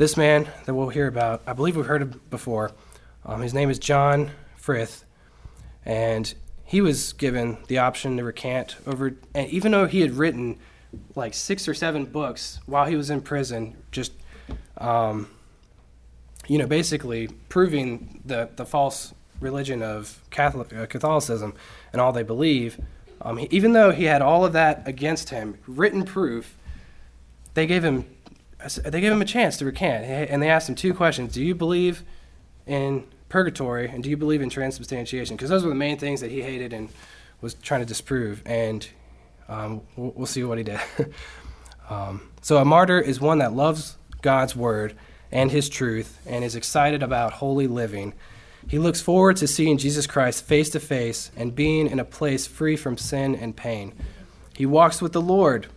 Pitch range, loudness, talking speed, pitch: 115-150 Hz, -23 LUFS, 180 wpm, 135 Hz